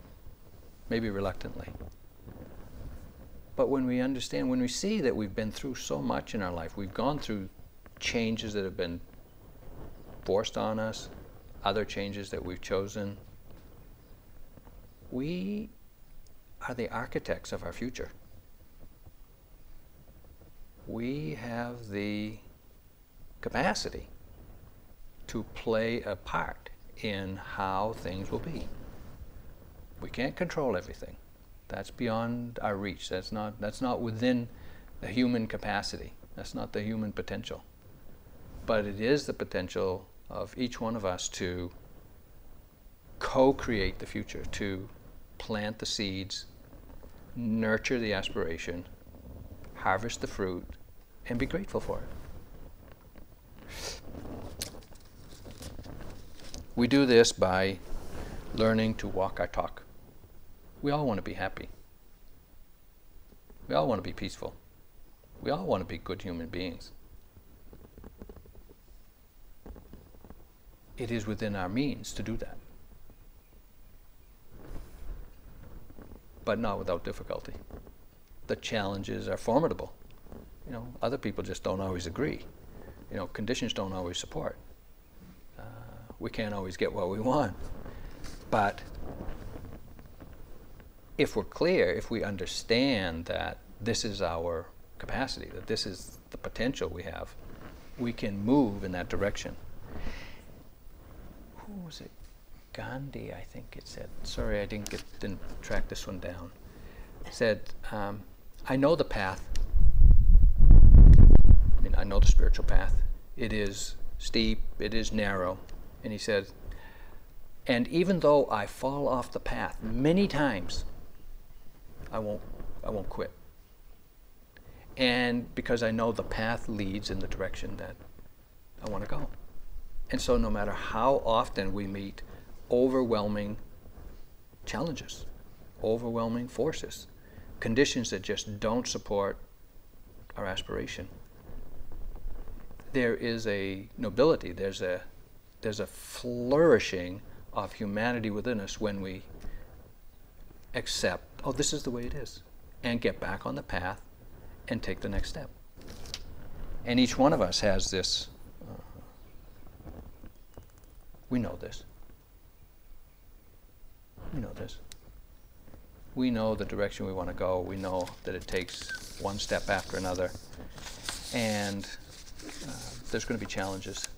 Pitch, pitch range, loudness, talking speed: 100 Hz, 90-110 Hz, -31 LUFS, 125 wpm